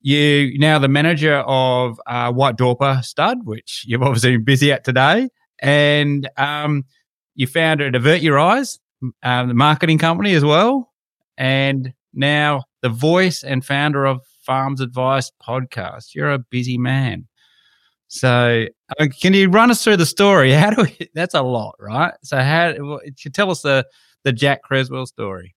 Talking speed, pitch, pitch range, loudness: 165 wpm, 140 Hz, 130-155 Hz, -16 LUFS